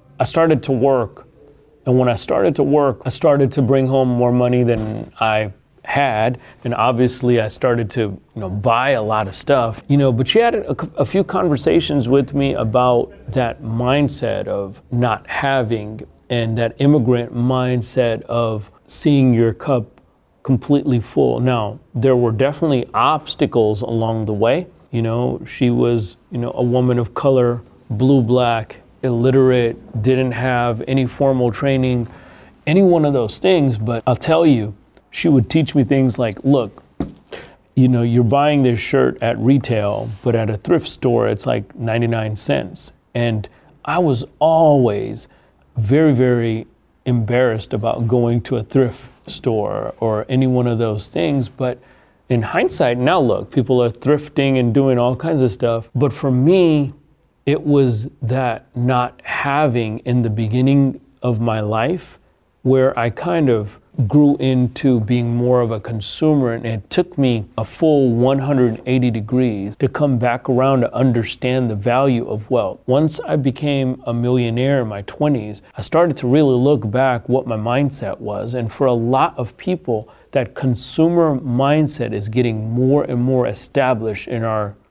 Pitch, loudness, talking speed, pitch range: 125 Hz, -17 LUFS, 160 wpm, 115-135 Hz